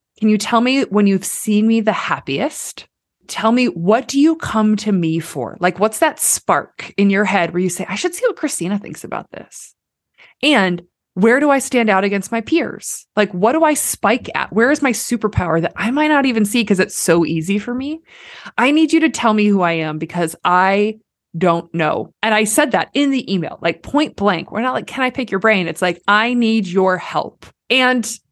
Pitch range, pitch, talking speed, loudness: 185-255 Hz, 215 Hz, 225 wpm, -16 LUFS